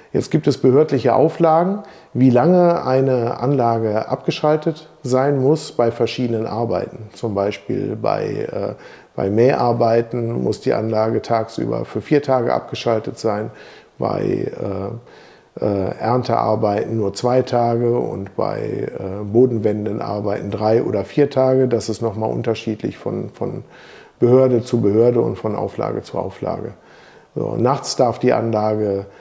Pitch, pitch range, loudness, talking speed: 115 Hz, 110-130 Hz, -19 LUFS, 130 wpm